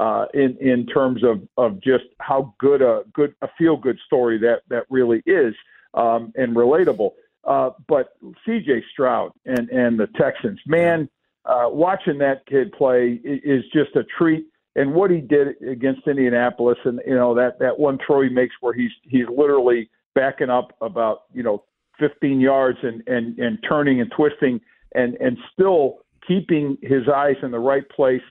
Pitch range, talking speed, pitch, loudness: 125-160 Hz, 175 wpm, 135 Hz, -20 LUFS